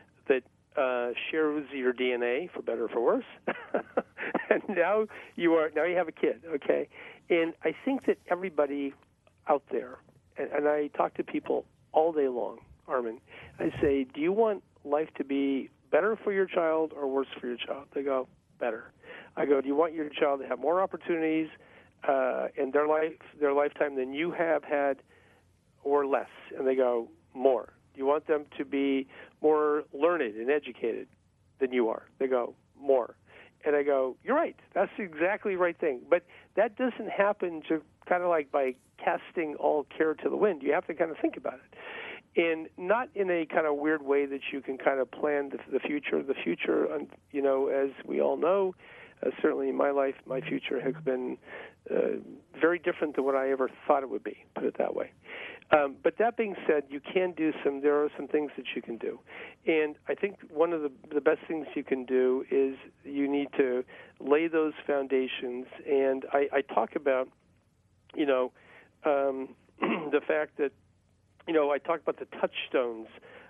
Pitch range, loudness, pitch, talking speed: 135-170 Hz, -30 LUFS, 145 Hz, 190 wpm